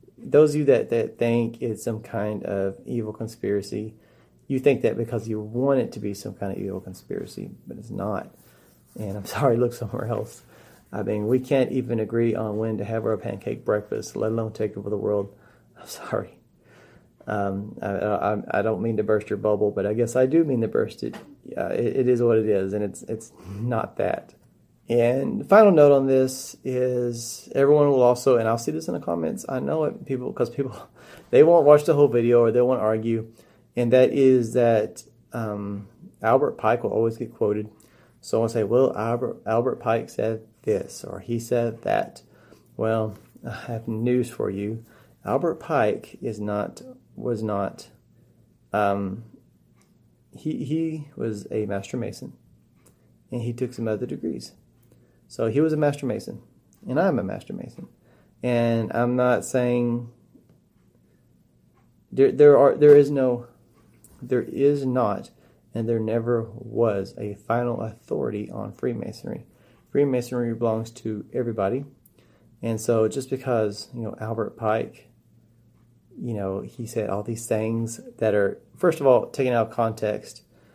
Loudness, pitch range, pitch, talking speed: -24 LUFS, 110-125 Hz, 115 Hz, 170 wpm